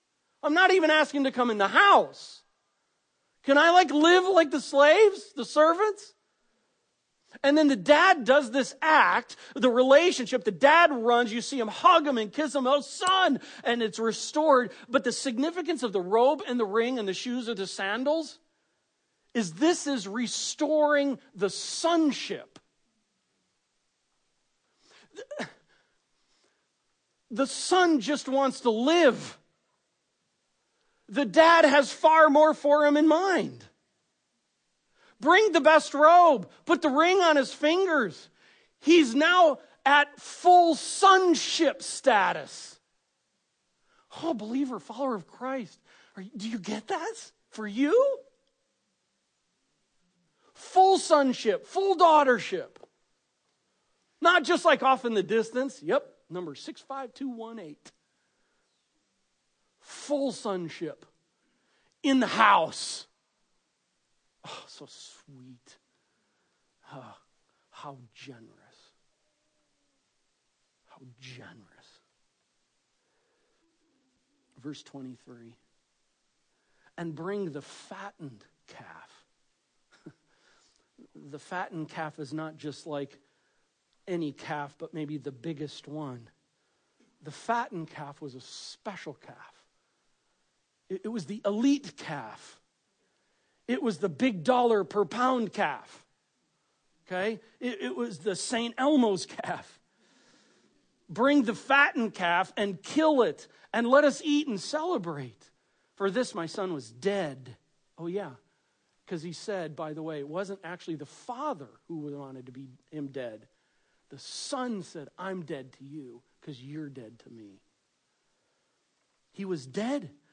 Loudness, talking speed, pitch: -25 LUFS, 115 wpm, 245 Hz